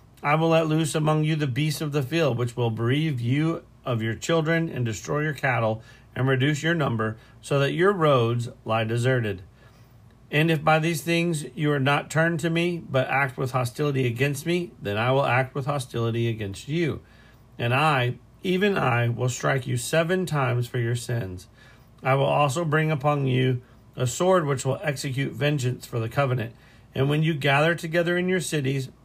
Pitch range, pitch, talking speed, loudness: 120-155 Hz, 135 Hz, 190 wpm, -24 LUFS